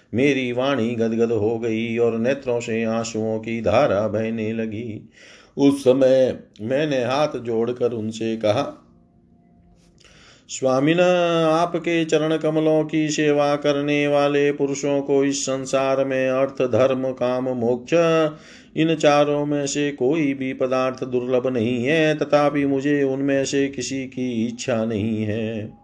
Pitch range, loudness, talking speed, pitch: 115-145 Hz, -21 LUFS, 130 wpm, 130 Hz